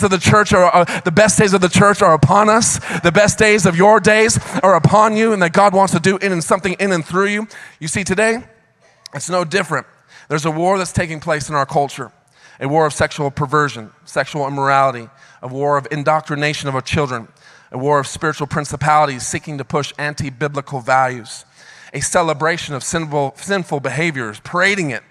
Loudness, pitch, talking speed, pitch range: -15 LUFS, 155 Hz, 200 wpm, 140-190 Hz